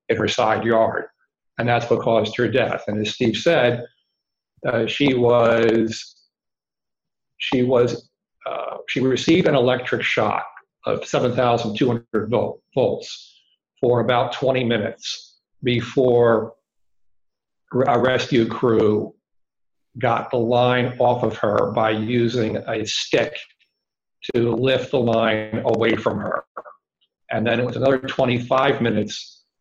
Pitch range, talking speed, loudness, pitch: 110-125 Hz, 120 wpm, -20 LUFS, 120 Hz